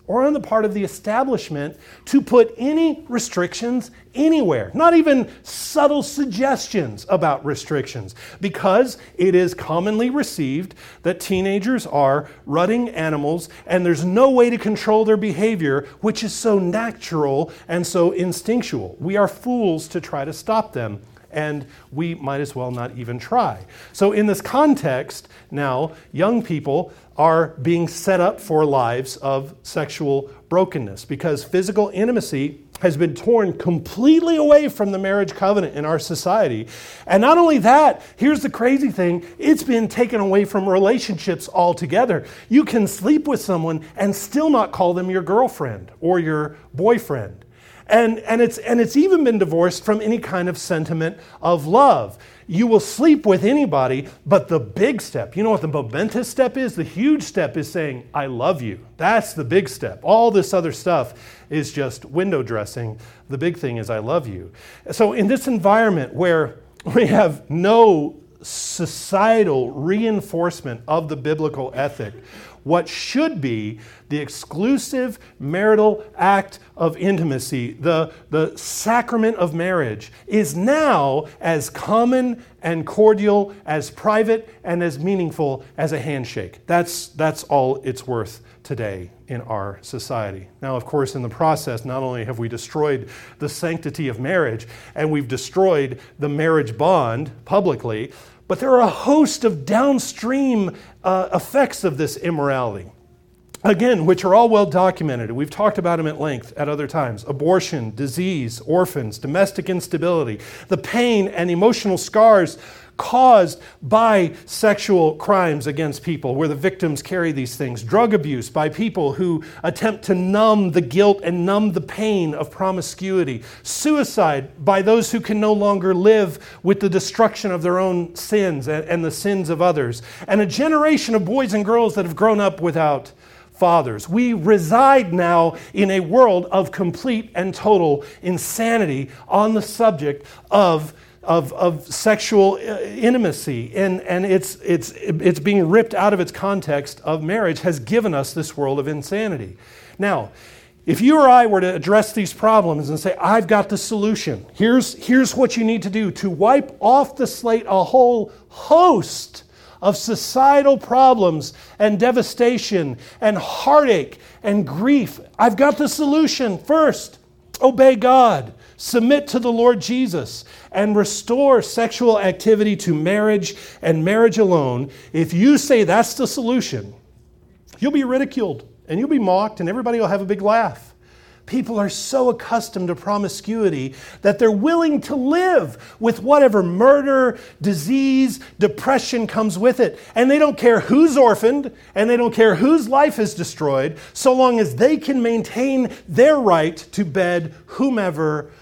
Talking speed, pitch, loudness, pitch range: 155 wpm, 190 Hz, -18 LUFS, 155-225 Hz